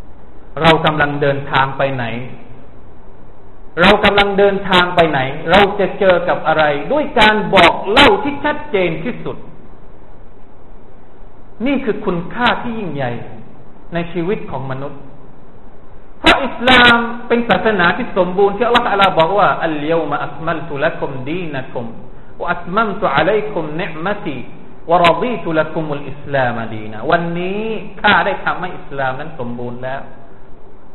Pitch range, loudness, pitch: 140-200 Hz, -15 LUFS, 170 Hz